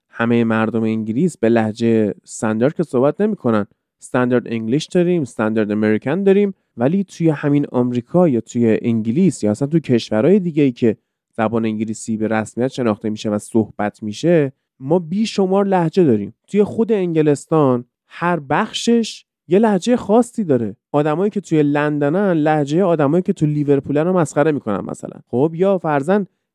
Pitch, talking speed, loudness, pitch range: 145 Hz, 155 wpm, -18 LUFS, 115-180 Hz